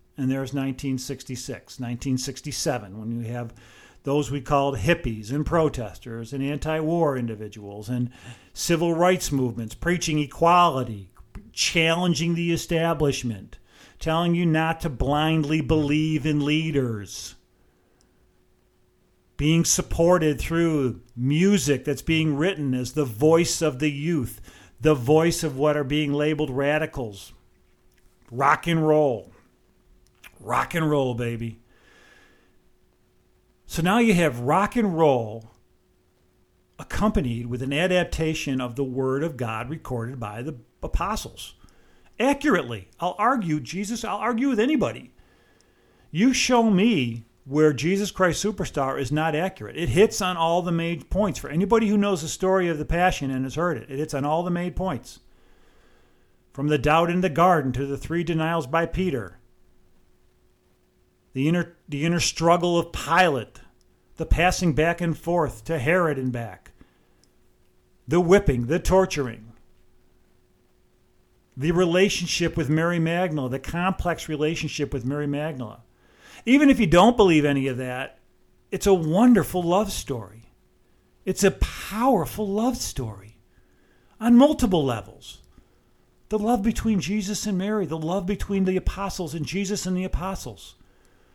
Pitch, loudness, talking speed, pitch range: 155 Hz, -23 LUFS, 135 wpm, 130-175 Hz